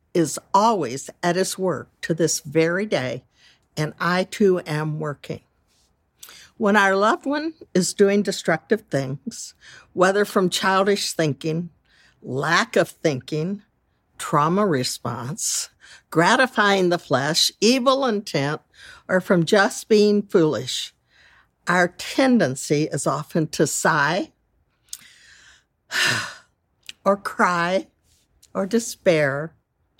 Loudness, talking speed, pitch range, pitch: -21 LUFS, 100 wpm, 160-205 Hz, 185 Hz